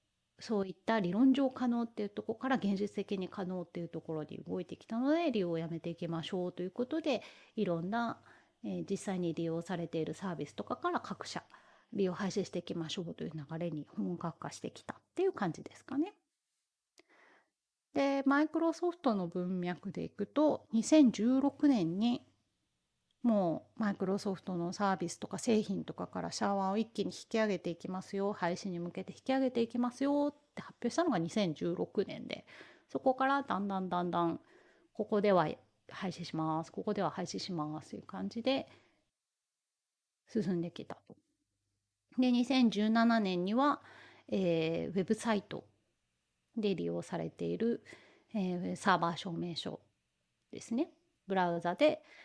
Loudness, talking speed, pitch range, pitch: -35 LUFS, 325 characters per minute, 175-245 Hz, 200 Hz